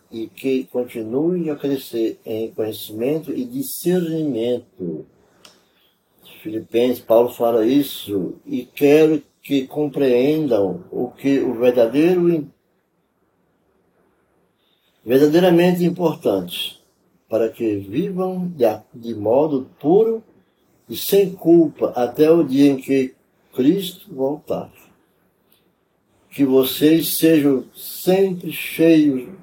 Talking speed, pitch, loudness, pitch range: 90 wpm, 145 Hz, -19 LUFS, 125-175 Hz